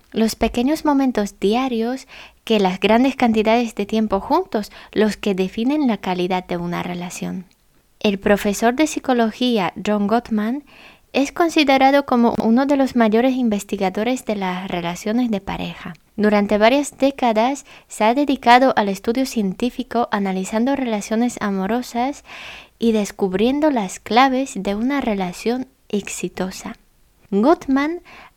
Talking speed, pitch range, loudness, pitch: 125 wpm, 205-260 Hz, -19 LUFS, 225 Hz